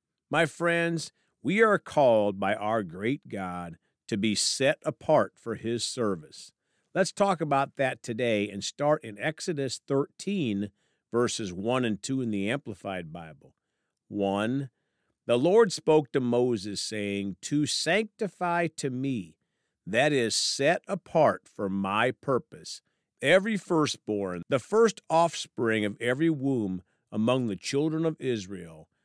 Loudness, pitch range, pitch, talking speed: -28 LUFS, 105-160 Hz, 130 Hz, 135 wpm